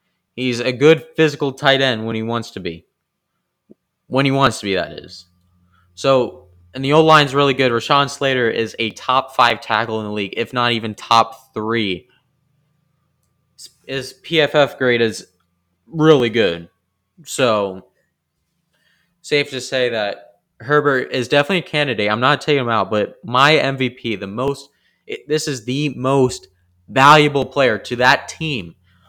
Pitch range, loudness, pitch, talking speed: 105-145 Hz, -17 LUFS, 125 Hz, 155 wpm